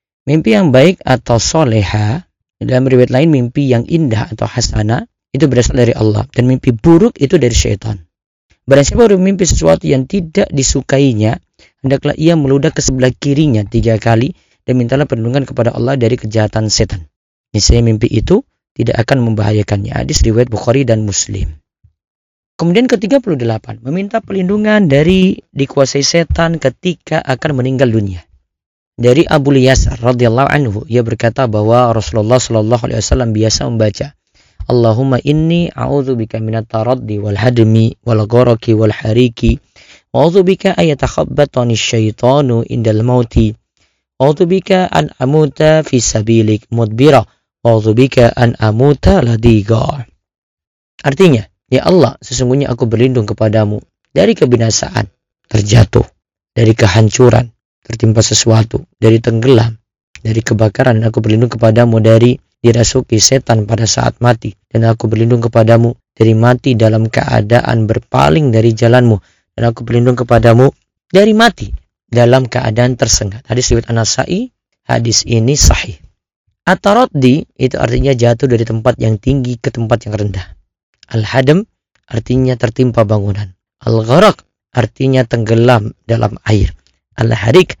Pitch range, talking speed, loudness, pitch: 110-135 Hz, 130 wpm, -11 LUFS, 120 Hz